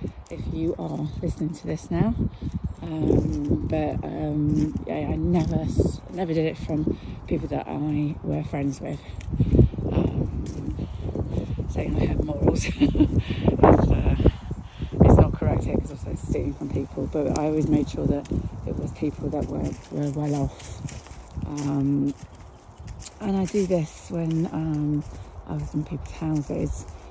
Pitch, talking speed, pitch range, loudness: 145 Hz, 145 wpm, 105-155 Hz, -25 LUFS